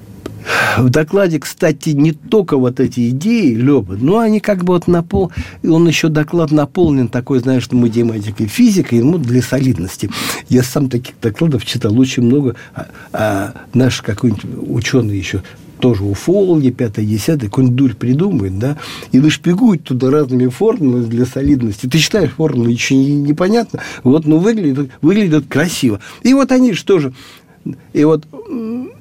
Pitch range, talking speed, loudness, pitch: 125-165 Hz, 155 wpm, -14 LUFS, 135 Hz